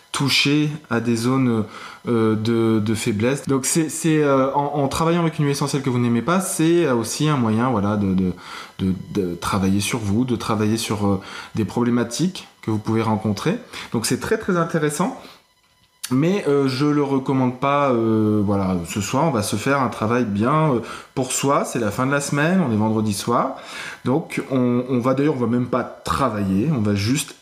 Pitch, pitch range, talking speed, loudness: 125 Hz, 110-145 Hz, 205 wpm, -20 LUFS